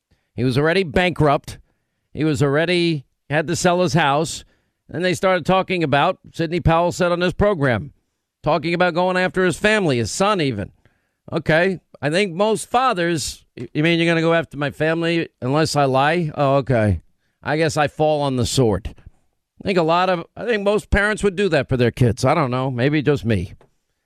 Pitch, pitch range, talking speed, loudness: 160 Hz, 135-180 Hz, 195 wpm, -19 LUFS